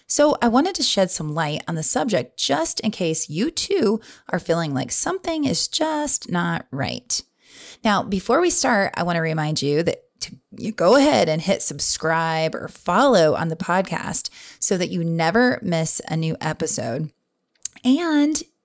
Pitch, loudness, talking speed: 190 Hz, -21 LUFS, 170 wpm